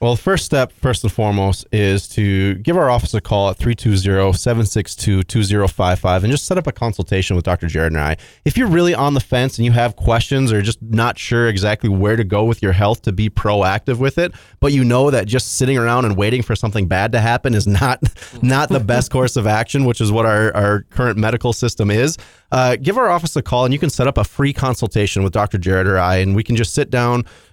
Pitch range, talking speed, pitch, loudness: 100-125 Hz, 235 wpm, 115 Hz, -16 LUFS